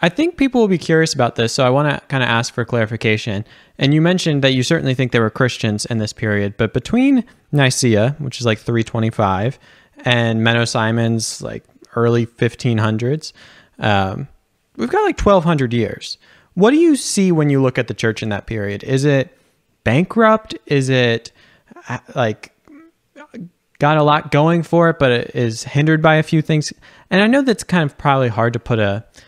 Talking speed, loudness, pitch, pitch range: 190 wpm, -16 LUFS, 130 Hz, 115-160 Hz